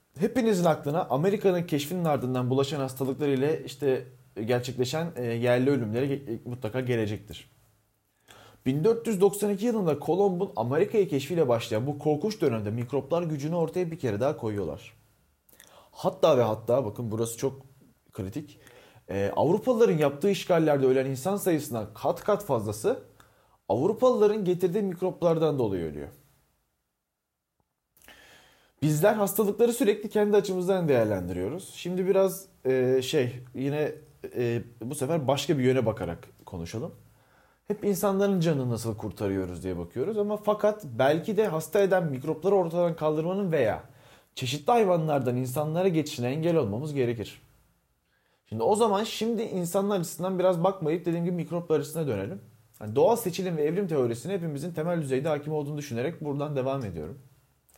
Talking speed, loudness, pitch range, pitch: 125 wpm, -27 LUFS, 125-185 Hz, 150 Hz